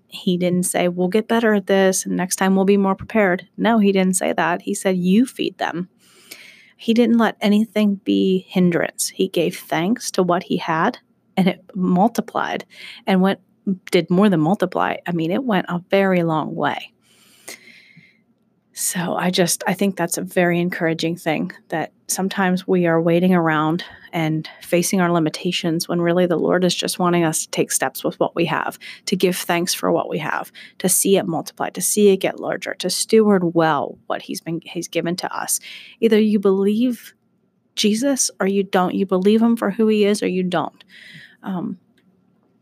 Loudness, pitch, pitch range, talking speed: -19 LUFS, 185 Hz, 175-205 Hz, 190 wpm